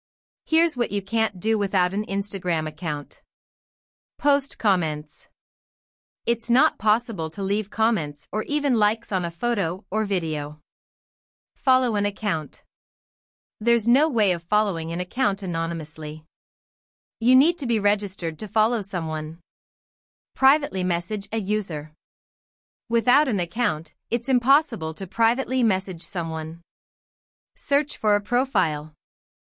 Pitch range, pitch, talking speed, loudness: 170-235 Hz, 205 Hz, 125 wpm, -24 LUFS